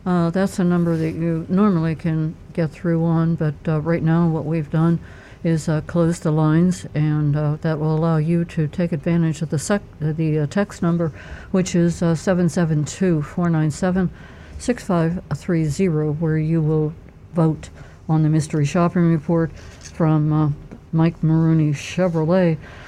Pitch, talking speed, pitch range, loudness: 165 Hz, 170 wpm, 155-175 Hz, -20 LUFS